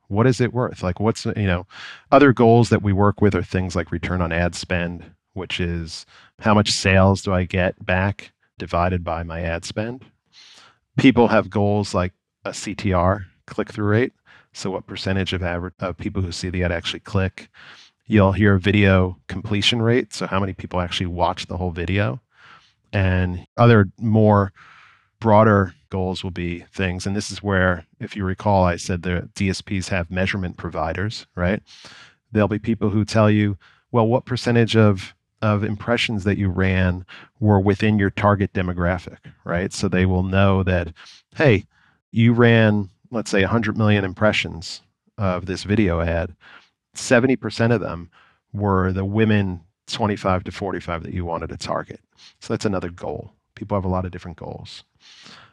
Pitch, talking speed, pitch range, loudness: 100 Hz, 170 wpm, 90-110 Hz, -20 LUFS